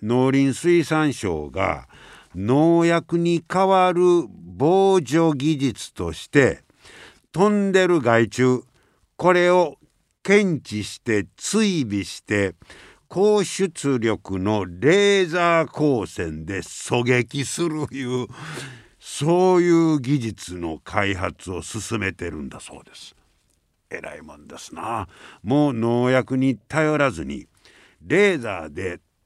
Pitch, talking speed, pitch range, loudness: 130 Hz, 200 characters per minute, 100-170 Hz, -21 LUFS